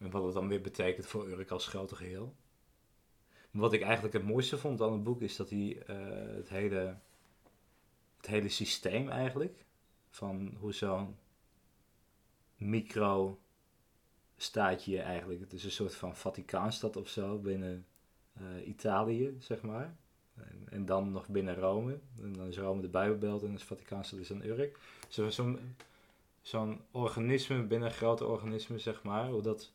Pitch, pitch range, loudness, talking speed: 105 Hz, 95-115 Hz, -37 LUFS, 160 wpm